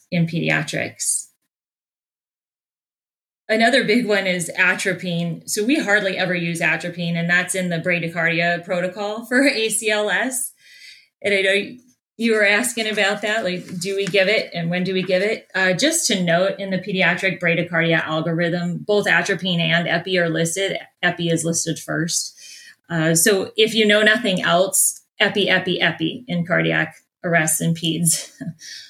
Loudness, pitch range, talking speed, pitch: -19 LUFS, 170-205 Hz, 155 wpm, 185 Hz